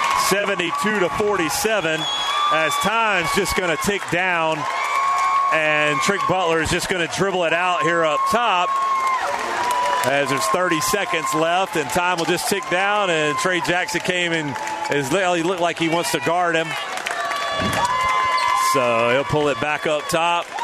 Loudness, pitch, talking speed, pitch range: -19 LUFS, 175 Hz, 160 wpm, 160-205 Hz